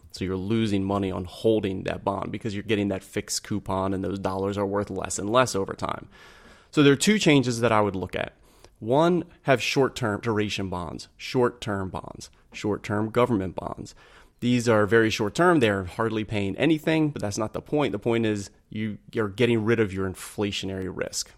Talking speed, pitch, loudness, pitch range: 200 wpm, 105 Hz, -25 LUFS, 95-120 Hz